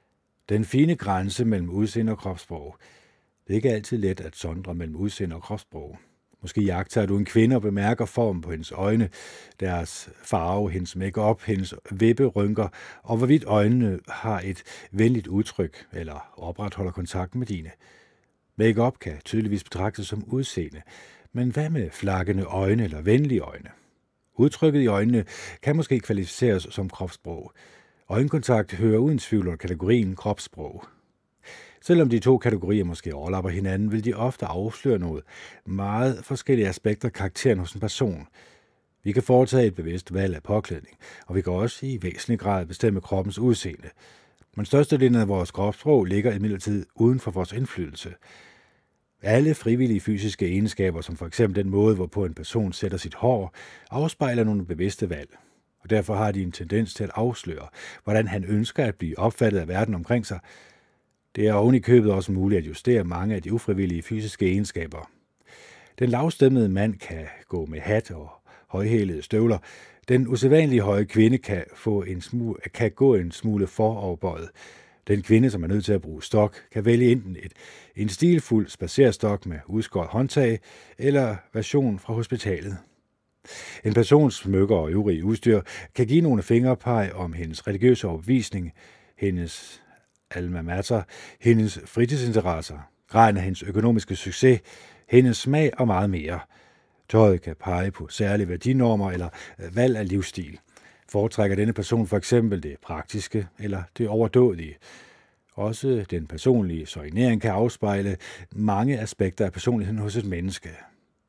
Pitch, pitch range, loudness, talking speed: 105 Hz, 95-115 Hz, -24 LUFS, 155 wpm